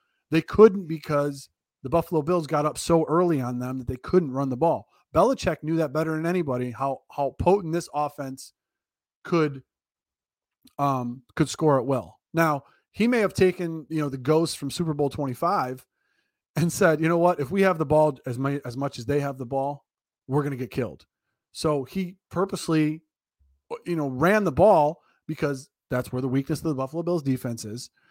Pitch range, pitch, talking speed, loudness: 135-170 Hz, 150 Hz, 195 wpm, -25 LUFS